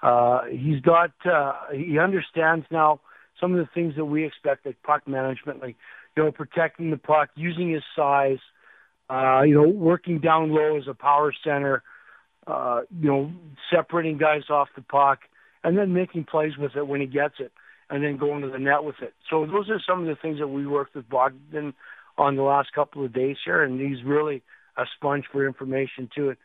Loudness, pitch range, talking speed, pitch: -24 LUFS, 140-160 Hz, 205 wpm, 145 Hz